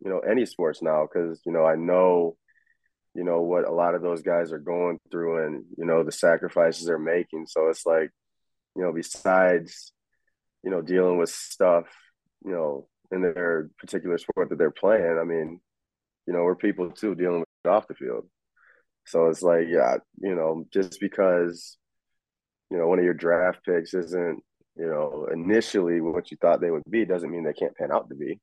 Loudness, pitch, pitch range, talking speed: -25 LUFS, 85 Hz, 80-90 Hz, 195 wpm